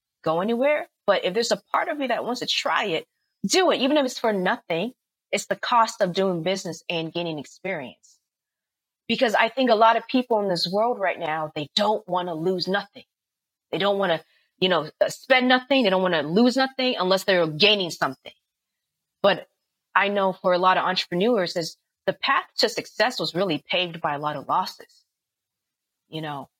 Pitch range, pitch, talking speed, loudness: 170-235 Hz, 195 Hz, 200 wpm, -23 LUFS